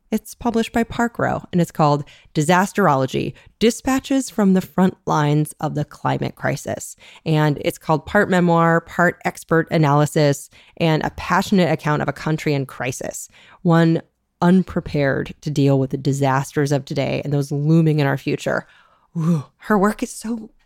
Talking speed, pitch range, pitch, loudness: 160 wpm, 145-185 Hz, 165 Hz, -19 LUFS